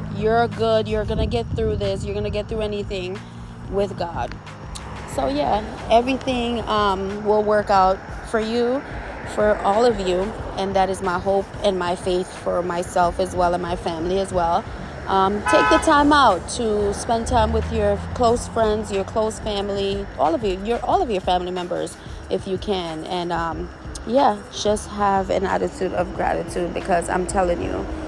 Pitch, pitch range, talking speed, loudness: 195 Hz, 175-215 Hz, 180 wpm, -21 LUFS